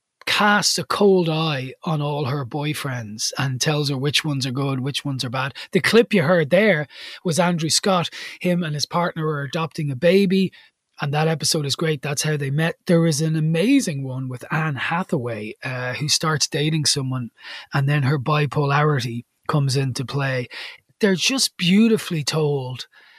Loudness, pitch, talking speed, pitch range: -21 LUFS, 150 Hz, 175 wpm, 140-170 Hz